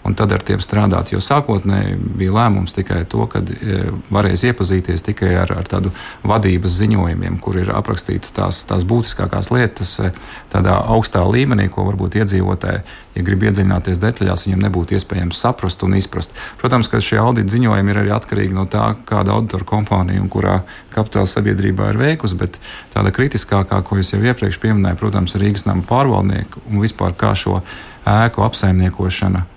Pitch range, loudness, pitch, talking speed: 95-110 Hz, -17 LUFS, 100 Hz, 160 wpm